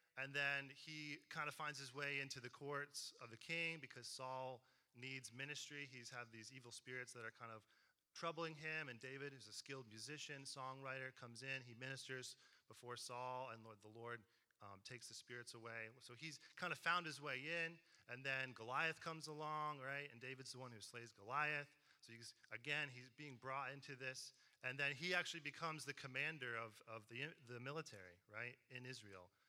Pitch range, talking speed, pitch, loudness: 120-145 Hz, 195 wpm, 130 Hz, -49 LUFS